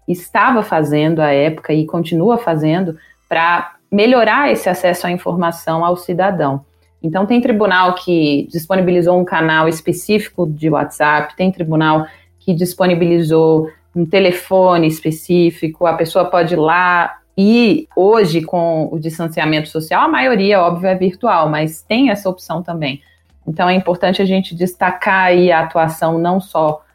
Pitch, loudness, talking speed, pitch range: 175 Hz, -14 LUFS, 145 wpm, 160-185 Hz